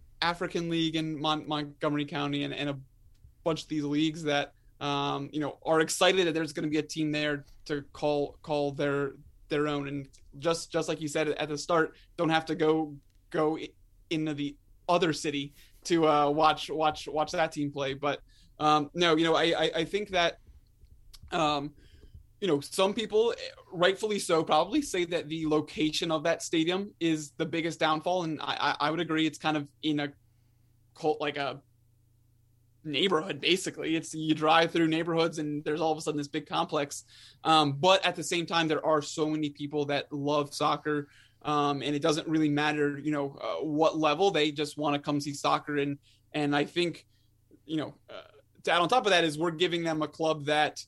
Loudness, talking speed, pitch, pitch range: -29 LUFS, 200 wpm, 155 Hz, 145-160 Hz